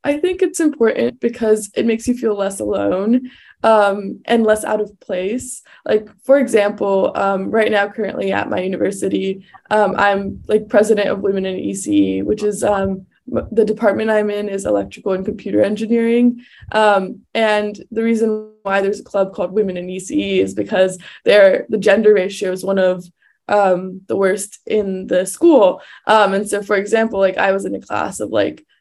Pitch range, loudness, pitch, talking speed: 190-220 Hz, -17 LUFS, 205 Hz, 180 wpm